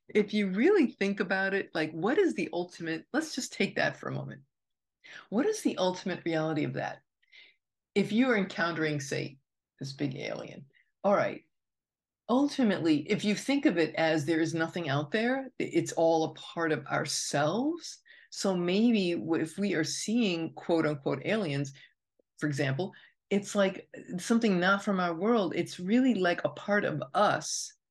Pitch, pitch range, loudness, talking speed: 185 Hz, 160-225 Hz, -30 LUFS, 170 wpm